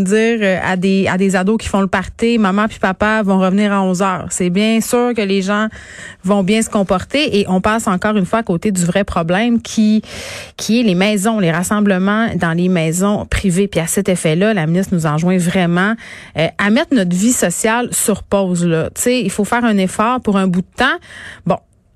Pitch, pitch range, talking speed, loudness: 200 Hz, 185-220 Hz, 210 wpm, -15 LUFS